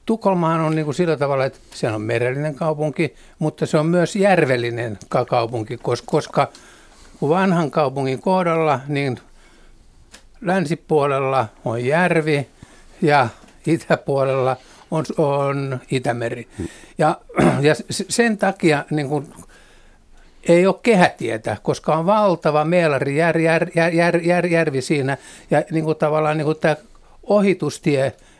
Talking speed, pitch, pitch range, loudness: 130 wpm, 155 Hz, 135-170 Hz, -19 LUFS